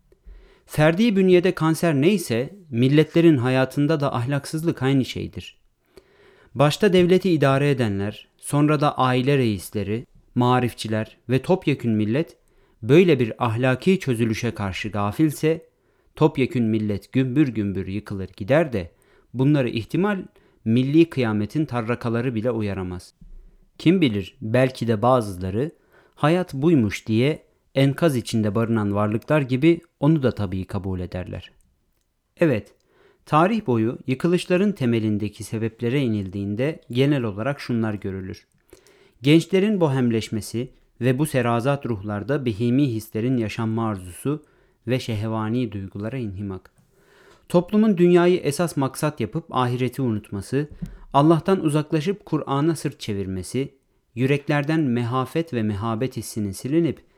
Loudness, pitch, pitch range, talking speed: -22 LUFS, 130 Hz, 110-155 Hz, 110 wpm